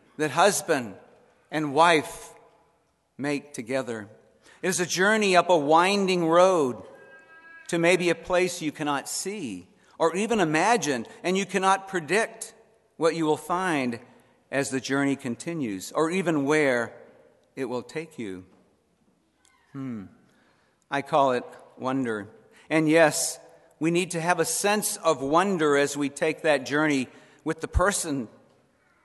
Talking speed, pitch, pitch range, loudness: 135 wpm, 165 Hz, 140-180 Hz, -25 LUFS